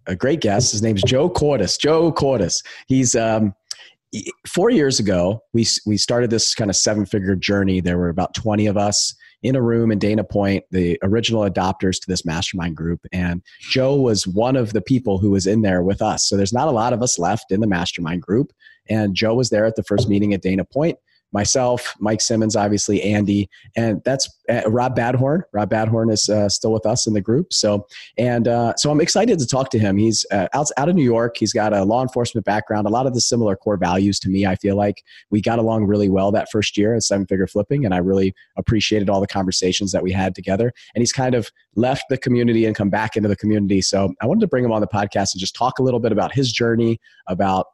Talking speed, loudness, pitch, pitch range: 235 wpm, -19 LUFS, 105 Hz, 100-115 Hz